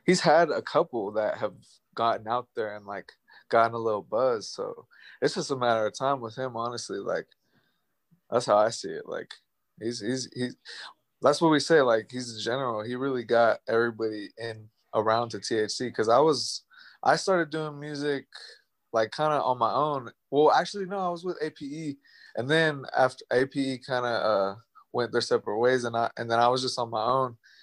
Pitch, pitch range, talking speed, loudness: 125 Hz, 115-150 Hz, 200 wpm, -27 LUFS